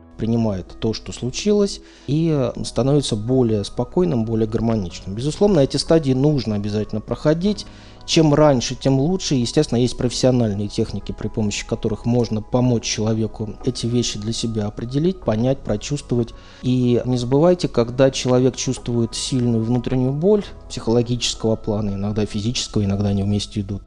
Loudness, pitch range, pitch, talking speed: -20 LUFS, 110-130 Hz, 120 Hz, 135 wpm